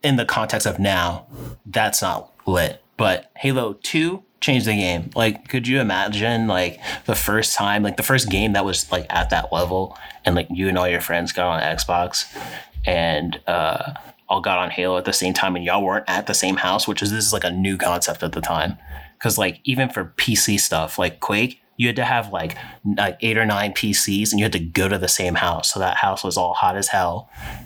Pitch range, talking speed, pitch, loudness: 90-110 Hz, 230 wpm, 100 Hz, -20 LUFS